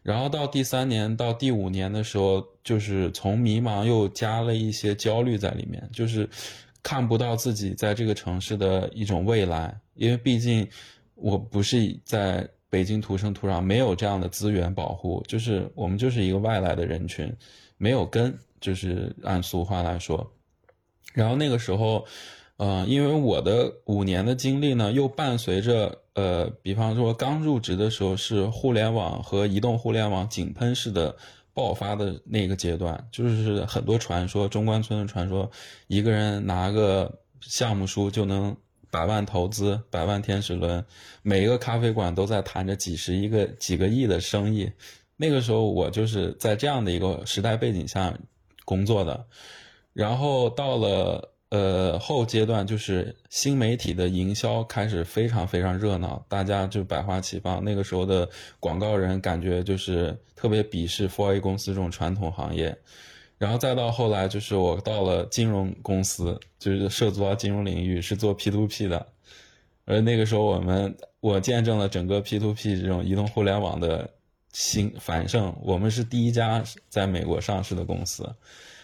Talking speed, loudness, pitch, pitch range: 260 characters per minute, -26 LUFS, 100 Hz, 95-115 Hz